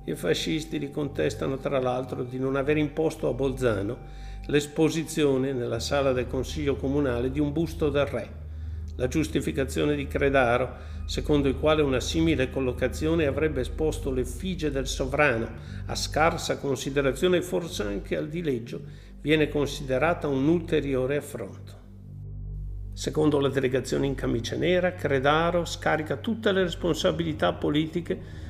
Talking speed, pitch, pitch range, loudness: 135 wpm, 135 Hz, 120-150 Hz, -26 LUFS